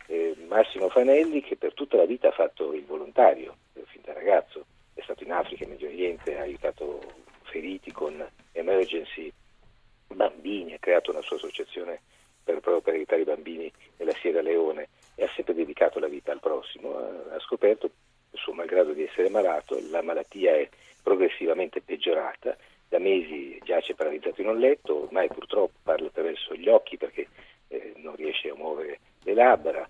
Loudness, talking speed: -27 LUFS, 165 wpm